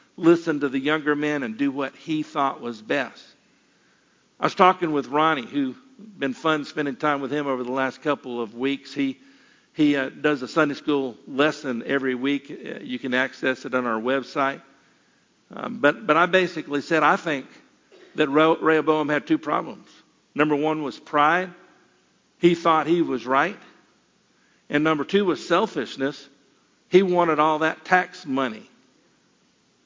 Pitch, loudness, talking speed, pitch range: 150 Hz, -23 LUFS, 165 wpm, 135-170 Hz